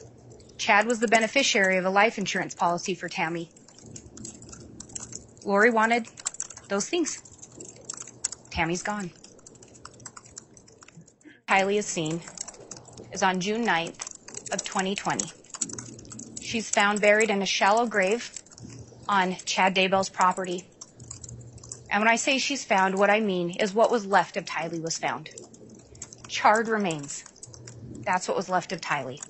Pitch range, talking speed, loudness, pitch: 170-210 Hz, 125 wpm, -25 LUFS, 190 Hz